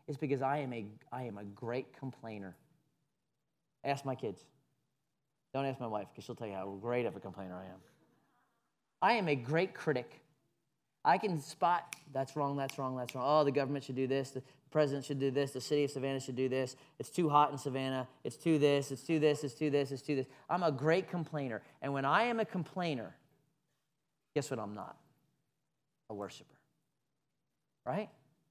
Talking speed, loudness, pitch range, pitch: 205 wpm, -35 LUFS, 130-155 Hz, 145 Hz